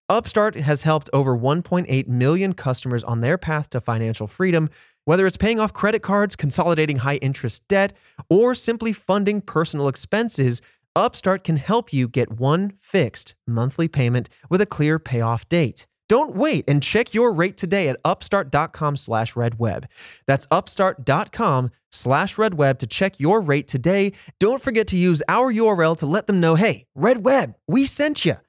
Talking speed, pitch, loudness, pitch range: 155 wpm, 160 Hz, -20 LUFS, 135-200 Hz